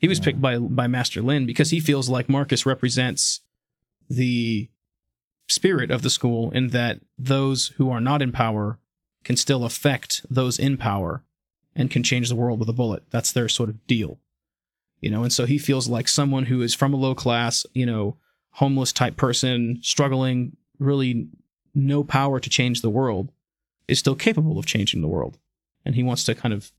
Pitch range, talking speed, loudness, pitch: 120-135 Hz, 190 wpm, -22 LUFS, 125 Hz